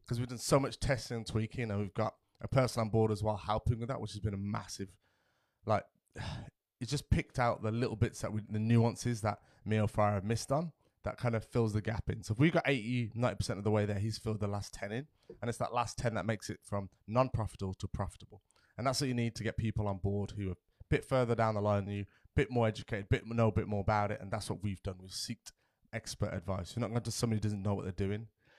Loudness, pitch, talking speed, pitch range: -35 LUFS, 110 Hz, 275 wpm, 105-120 Hz